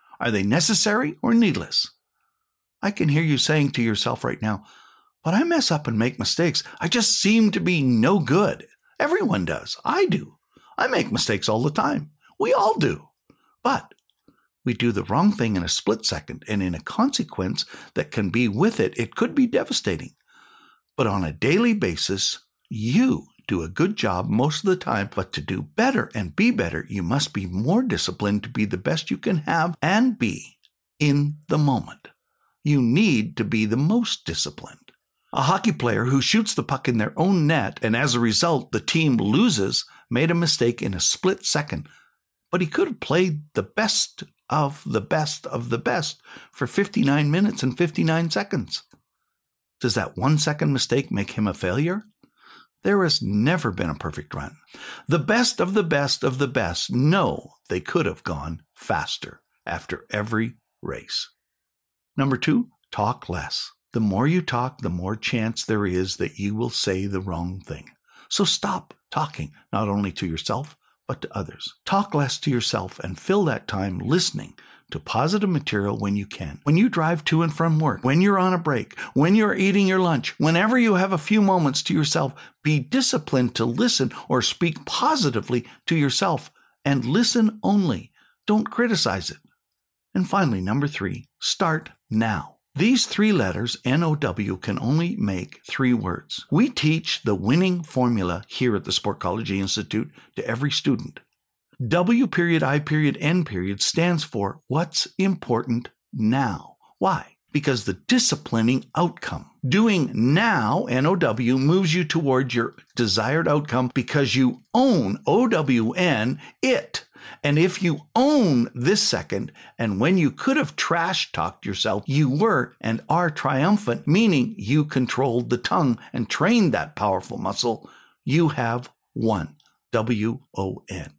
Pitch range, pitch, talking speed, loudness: 115-180 Hz, 145 Hz, 170 wpm, -23 LUFS